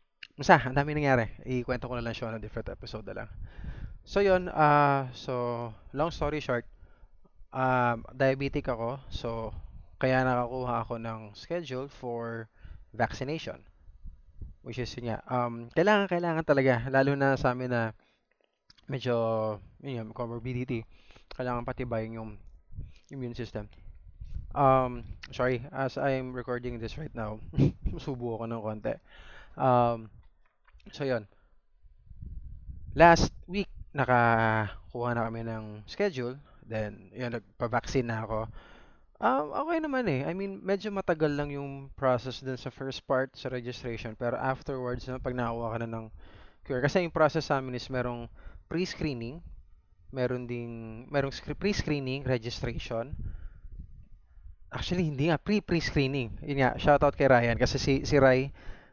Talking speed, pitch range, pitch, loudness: 140 wpm, 110-135 Hz, 125 Hz, -30 LUFS